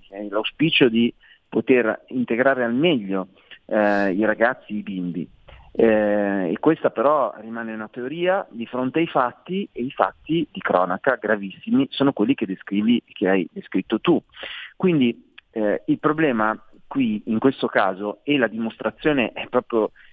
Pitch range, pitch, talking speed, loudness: 105-140 Hz, 115 Hz, 150 wpm, -22 LUFS